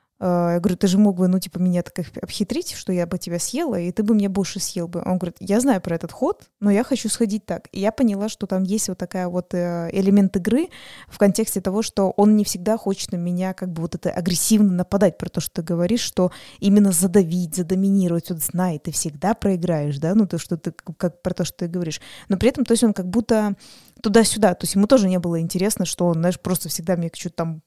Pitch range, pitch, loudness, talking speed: 175-205 Hz, 185 Hz, -21 LUFS, 245 wpm